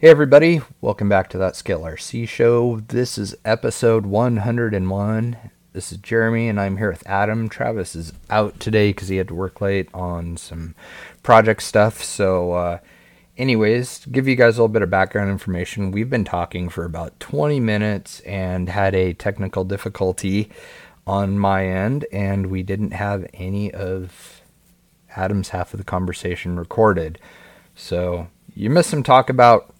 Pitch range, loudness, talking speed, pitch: 95-115 Hz, -19 LUFS, 165 wpm, 100 Hz